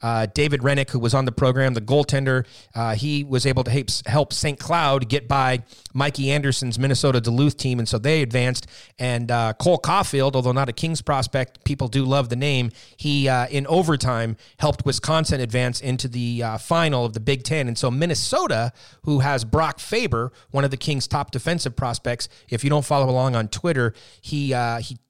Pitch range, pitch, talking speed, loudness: 120-145 Hz, 130 Hz, 200 wpm, -22 LUFS